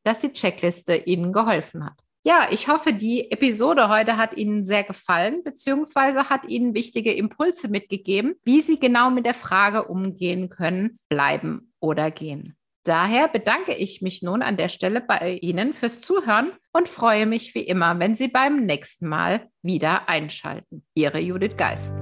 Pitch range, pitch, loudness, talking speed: 175-245 Hz, 210 Hz, -22 LUFS, 165 wpm